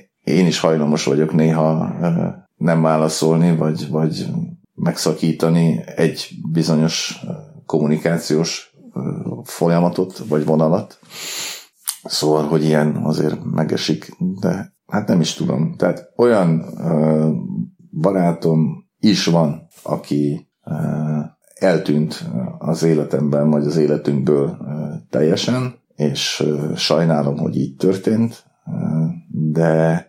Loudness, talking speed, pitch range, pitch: -18 LUFS, 90 wpm, 75-85 Hz, 80 Hz